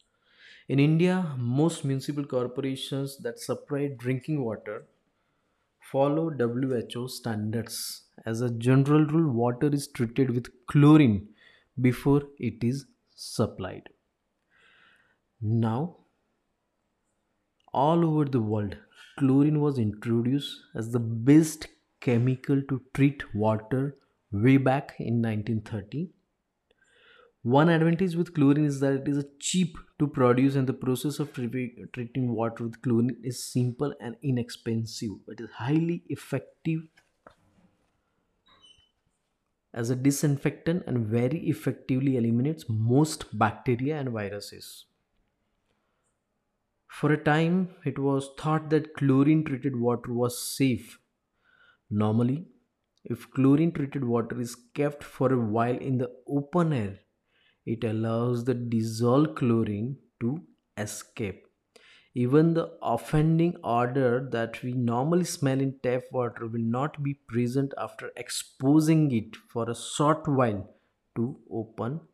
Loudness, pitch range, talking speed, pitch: -27 LUFS, 115-145 Hz, 115 wpm, 130 Hz